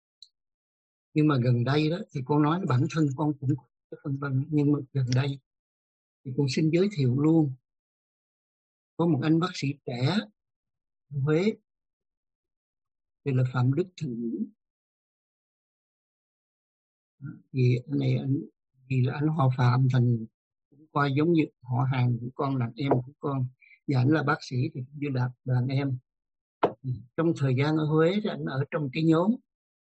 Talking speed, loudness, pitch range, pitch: 155 wpm, -27 LUFS, 125-155 Hz, 140 Hz